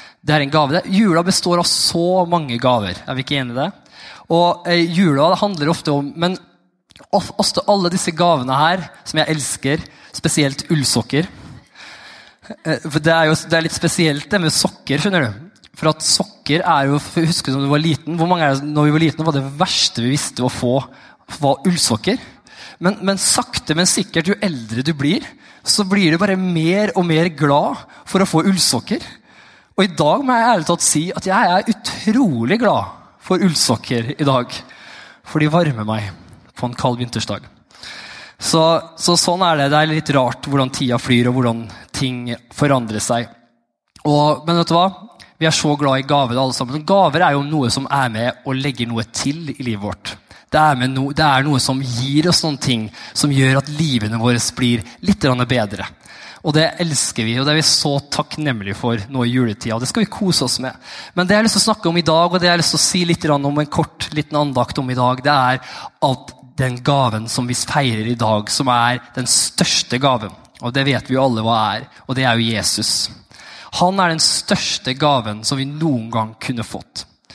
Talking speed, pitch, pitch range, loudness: 200 wpm, 145 Hz, 125-170 Hz, -17 LUFS